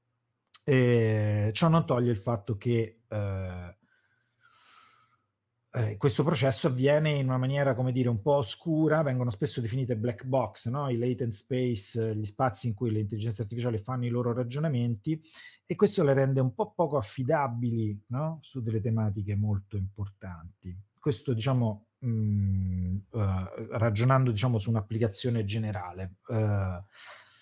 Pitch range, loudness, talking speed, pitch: 105-130 Hz, -29 LUFS, 140 wpm, 120 Hz